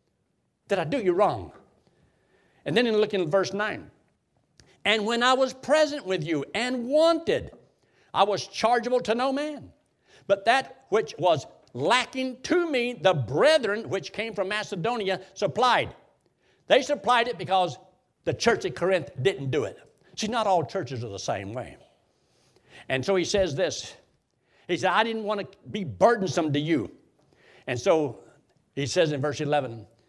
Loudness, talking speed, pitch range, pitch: -26 LUFS, 165 wpm, 180-245 Hz, 200 Hz